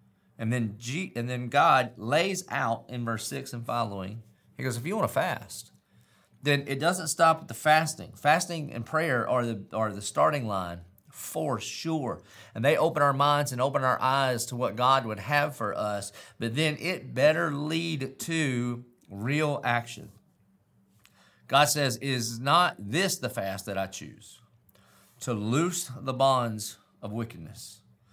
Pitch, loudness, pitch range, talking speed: 125 Hz, -28 LUFS, 115-150 Hz, 165 wpm